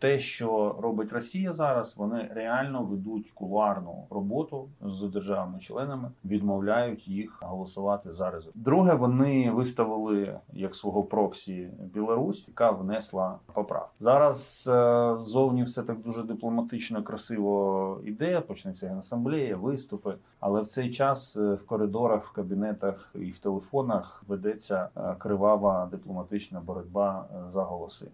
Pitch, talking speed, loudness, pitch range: 110 Hz, 120 wpm, -29 LUFS, 100-125 Hz